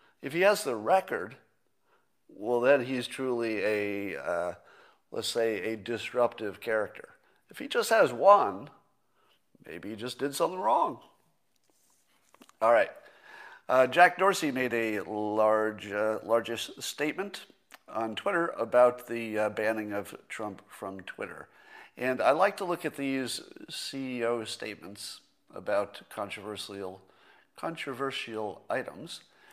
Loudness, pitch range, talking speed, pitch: -29 LUFS, 105-140 Hz, 125 wpm, 120 Hz